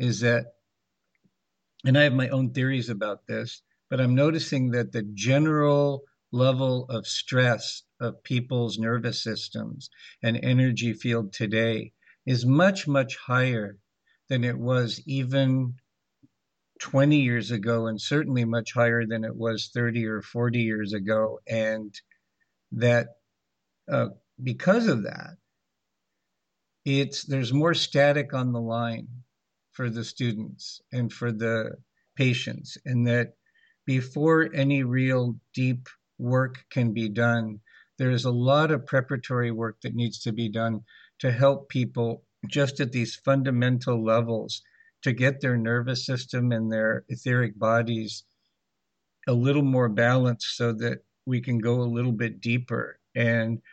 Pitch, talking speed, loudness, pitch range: 120 Hz, 135 wpm, -26 LUFS, 115-130 Hz